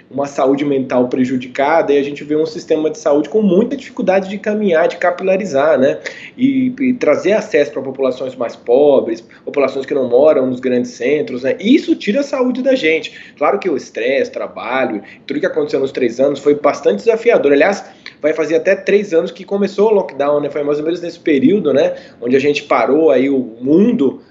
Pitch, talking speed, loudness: 180 Hz, 200 wpm, -15 LUFS